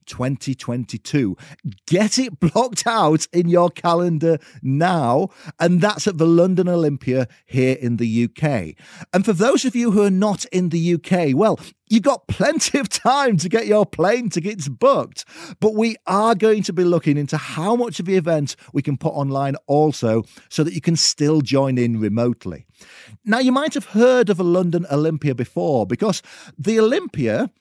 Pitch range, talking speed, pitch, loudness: 140-205 Hz, 175 wpm, 170 Hz, -19 LUFS